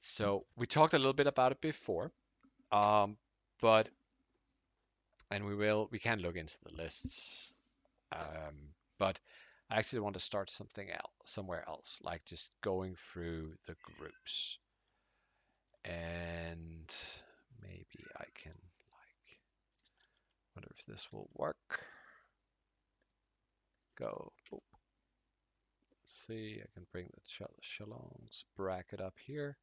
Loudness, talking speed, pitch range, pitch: -38 LUFS, 120 wpm, 85-115 Hz, 100 Hz